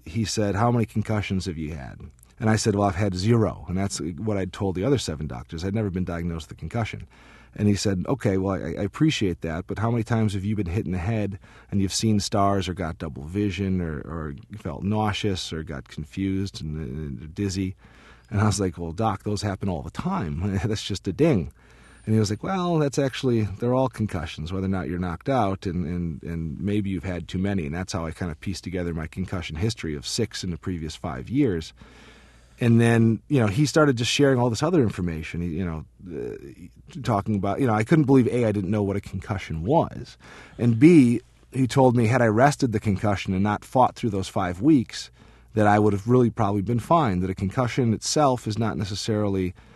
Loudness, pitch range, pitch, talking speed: -24 LUFS, 90-110 Hz, 100 Hz, 225 wpm